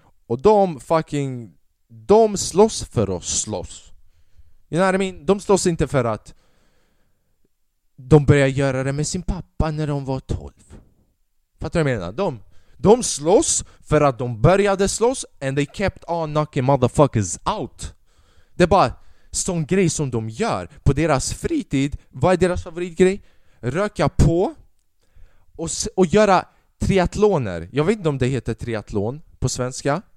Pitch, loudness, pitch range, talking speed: 140 Hz, -20 LUFS, 110-180 Hz, 150 wpm